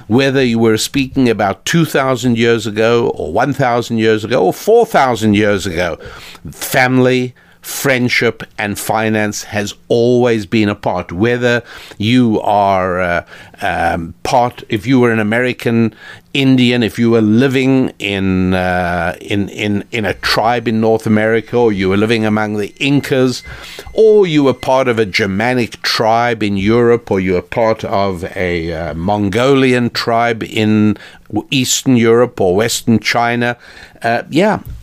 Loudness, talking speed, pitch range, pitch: -13 LUFS, 145 wpm, 105-125 Hz, 115 Hz